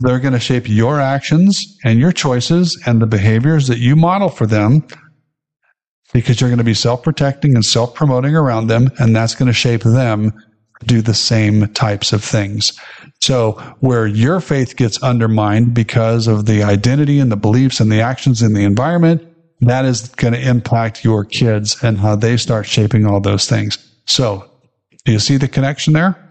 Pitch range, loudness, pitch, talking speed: 110-140 Hz, -14 LUFS, 120 Hz, 185 wpm